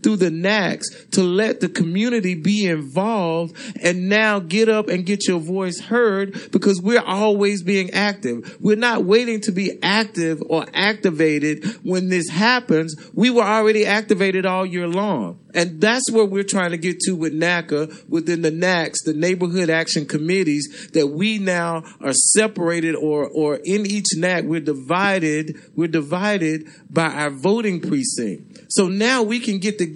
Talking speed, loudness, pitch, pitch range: 165 wpm, -19 LUFS, 185 Hz, 165-210 Hz